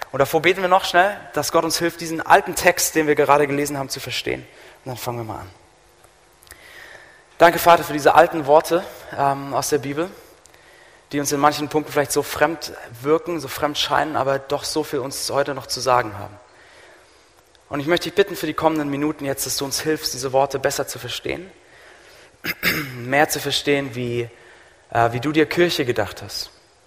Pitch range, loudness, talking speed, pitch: 135-160 Hz, -20 LUFS, 195 wpm, 145 Hz